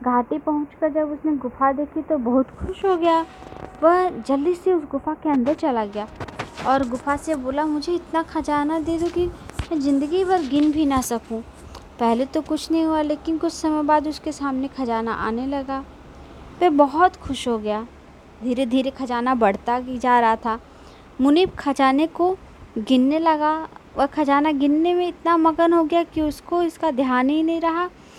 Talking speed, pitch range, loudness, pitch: 180 wpm, 265-325 Hz, -21 LUFS, 300 Hz